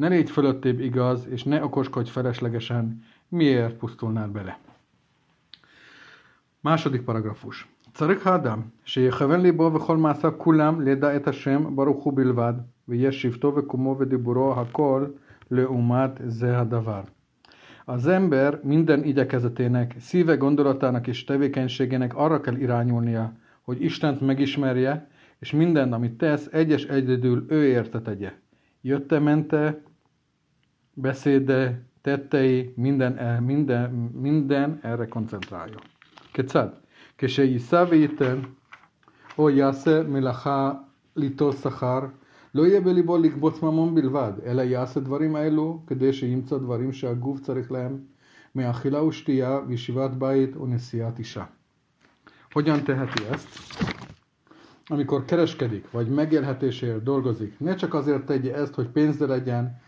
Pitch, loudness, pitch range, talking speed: 135 Hz, -24 LUFS, 125-145 Hz, 95 wpm